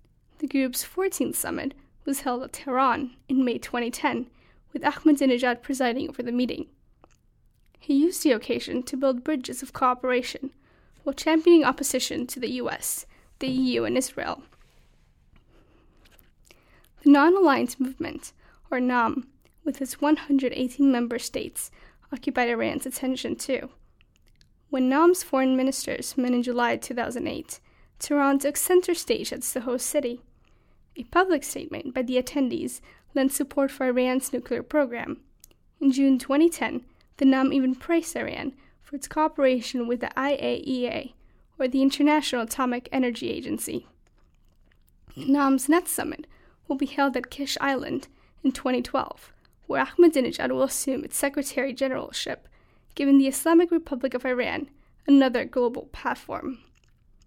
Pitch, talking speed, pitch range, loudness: 270 Hz, 135 wpm, 255-290 Hz, -25 LUFS